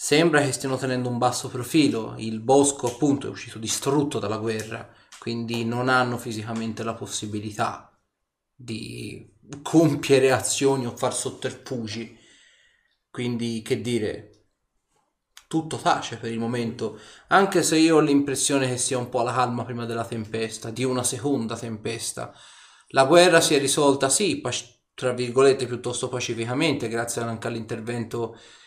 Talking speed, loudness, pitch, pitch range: 140 wpm, -24 LUFS, 125 Hz, 115-135 Hz